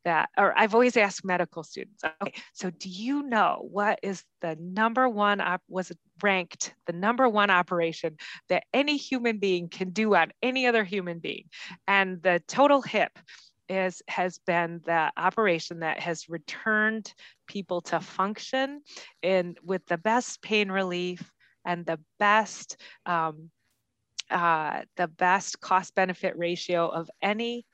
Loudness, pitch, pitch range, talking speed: -27 LUFS, 185 Hz, 175-215 Hz, 145 wpm